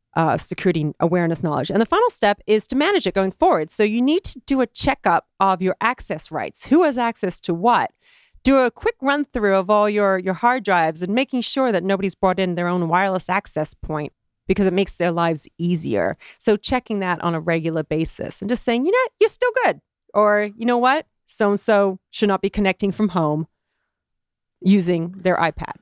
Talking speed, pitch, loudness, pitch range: 210 wpm, 200 Hz, -20 LUFS, 180-245 Hz